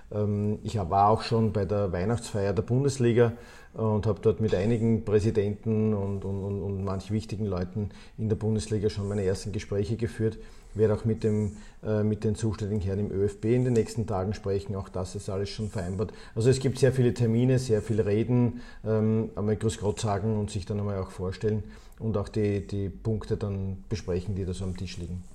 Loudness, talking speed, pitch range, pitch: -28 LUFS, 195 wpm, 100-110 Hz, 105 Hz